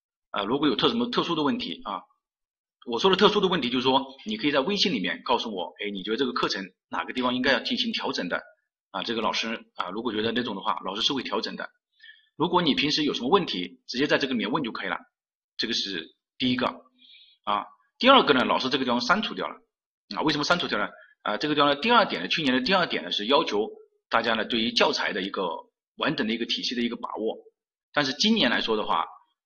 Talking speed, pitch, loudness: 360 characters per minute, 200 Hz, -25 LUFS